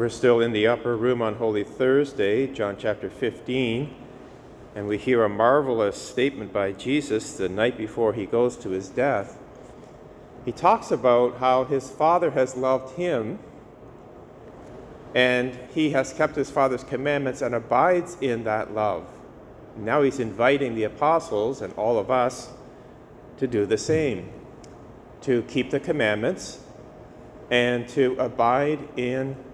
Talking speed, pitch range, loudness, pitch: 140 wpm, 115-135 Hz, -24 LUFS, 125 Hz